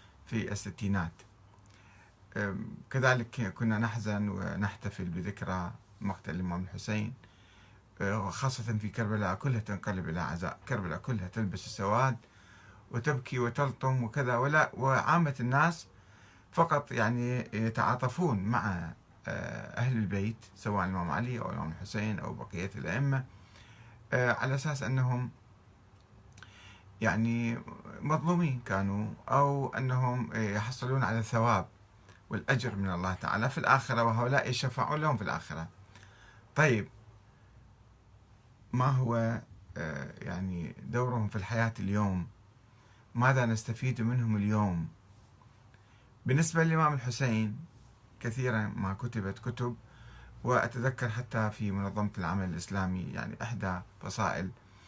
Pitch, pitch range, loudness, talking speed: 110 Hz, 100-125 Hz, -32 LUFS, 100 wpm